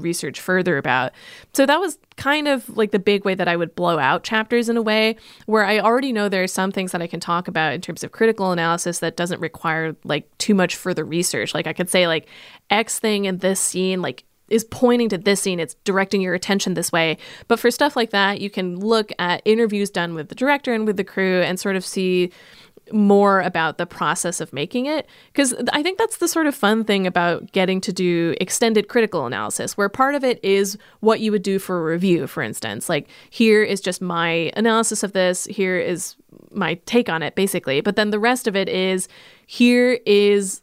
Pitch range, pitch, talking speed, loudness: 175-220 Hz, 195 Hz, 225 wpm, -20 LUFS